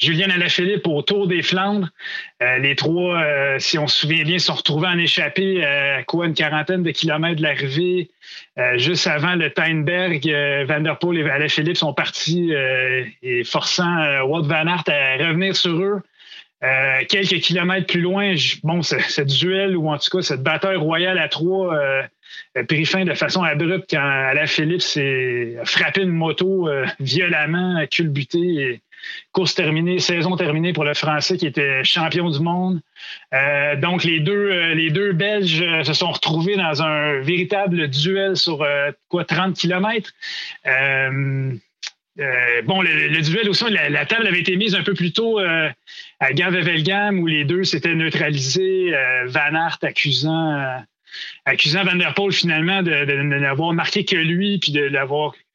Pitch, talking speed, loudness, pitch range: 165 Hz, 175 wpm, -18 LUFS, 150-185 Hz